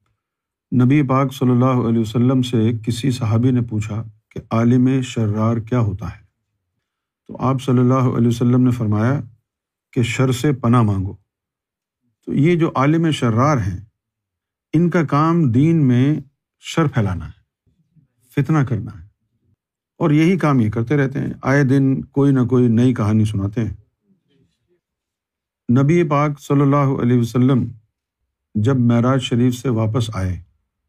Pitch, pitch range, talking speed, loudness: 125 Hz, 110-135 Hz, 150 wpm, -17 LUFS